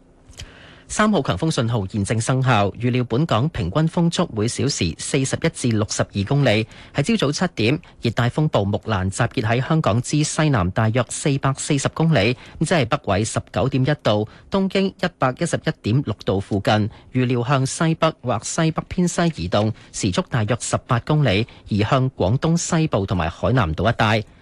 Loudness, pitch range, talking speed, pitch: -21 LUFS, 110-155 Hz, 275 characters per minute, 125 Hz